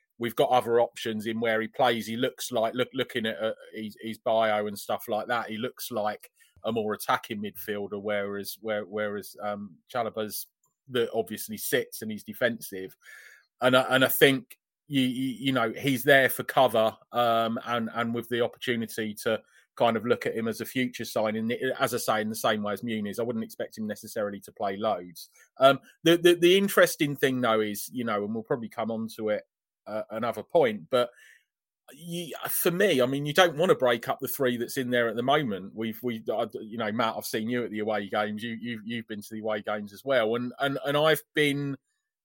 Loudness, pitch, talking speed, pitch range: -27 LUFS, 115 Hz, 220 wpm, 110-130 Hz